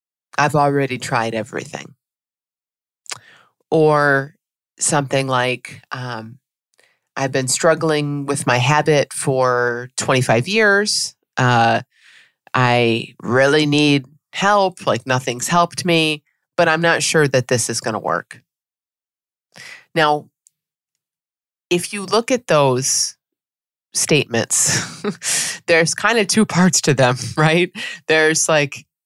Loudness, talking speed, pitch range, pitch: -17 LUFS, 110 wpm, 125-160 Hz, 145 Hz